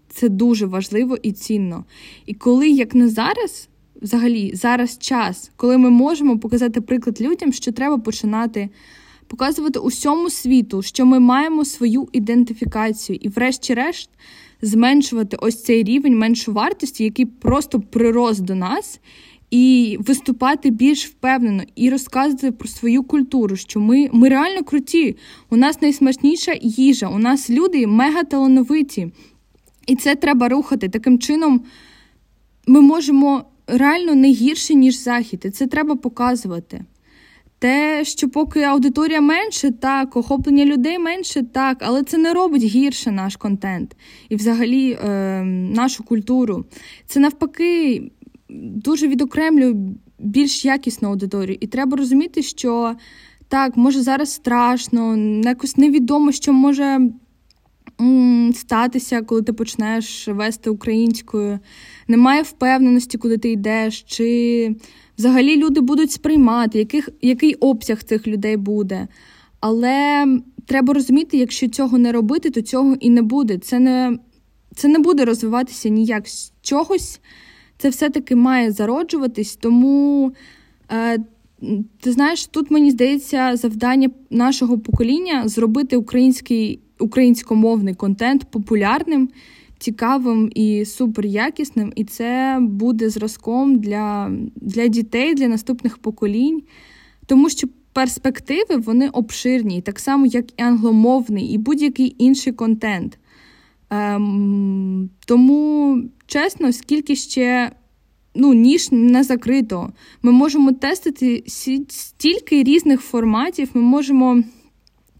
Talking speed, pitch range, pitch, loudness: 120 wpm, 230-275 Hz, 250 Hz, -17 LUFS